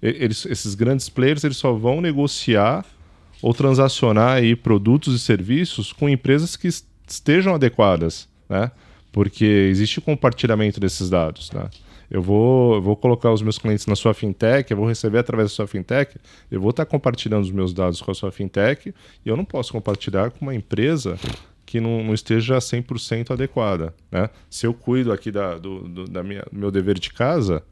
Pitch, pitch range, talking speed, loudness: 110 Hz, 95-125 Hz, 180 wpm, -20 LUFS